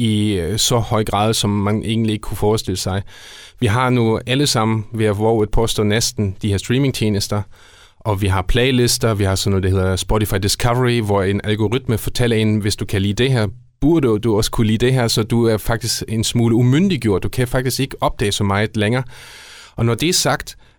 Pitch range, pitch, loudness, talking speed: 105-120 Hz, 110 Hz, -17 LUFS, 210 wpm